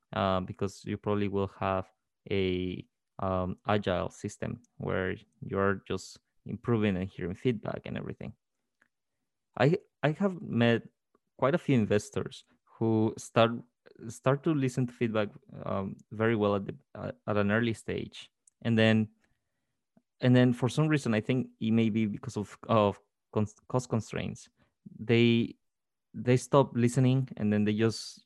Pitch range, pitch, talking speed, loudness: 105-125 Hz, 110 Hz, 150 wpm, -30 LUFS